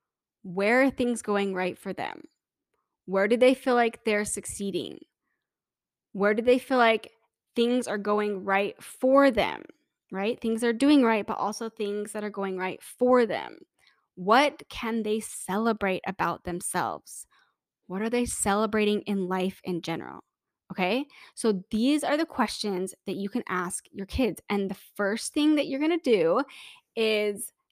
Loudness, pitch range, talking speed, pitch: -27 LUFS, 200-255 Hz, 160 wpm, 220 Hz